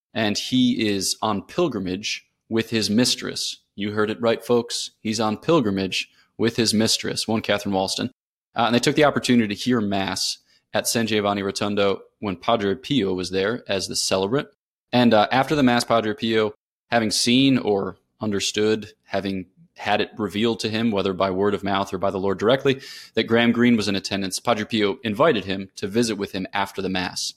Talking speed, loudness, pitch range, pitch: 190 wpm, -22 LUFS, 100-120 Hz, 110 Hz